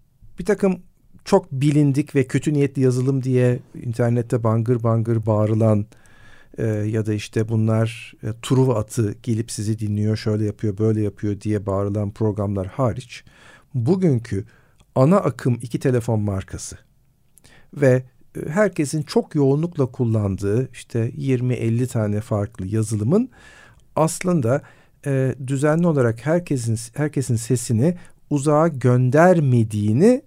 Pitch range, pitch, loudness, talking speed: 110-145 Hz, 125 Hz, -21 LUFS, 115 wpm